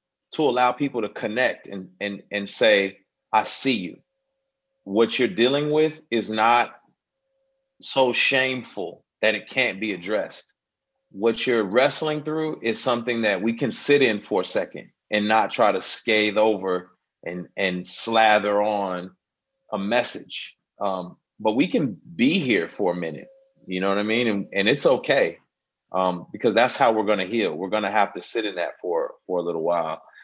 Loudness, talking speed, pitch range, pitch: -23 LUFS, 175 wpm, 105-155 Hz, 115 Hz